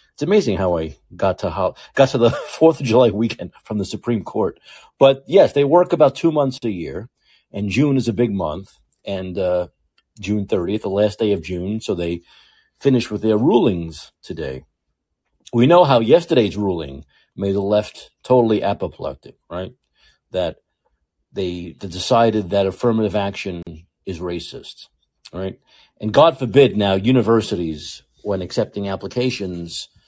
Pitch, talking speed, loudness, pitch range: 105 Hz, 155 wpm, -19 LUFS, 90-120 Hz